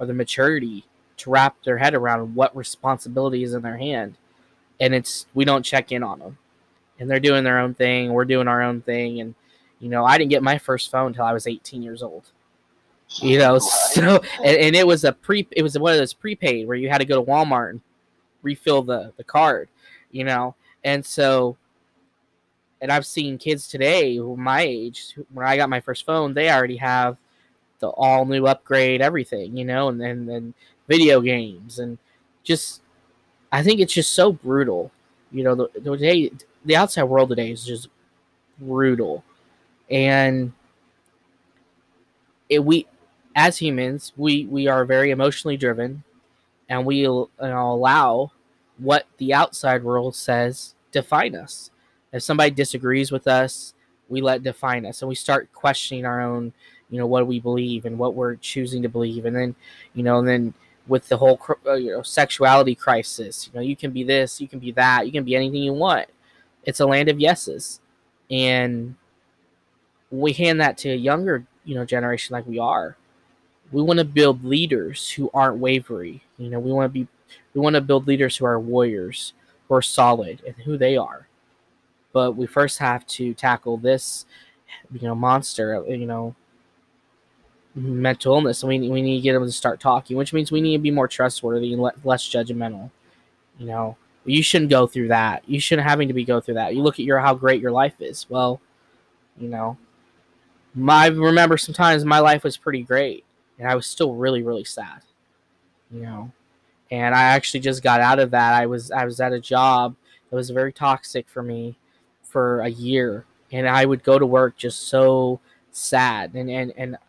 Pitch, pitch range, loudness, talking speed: 125 Hz, 120-135 Hz, -20 LUFS, 190 wpm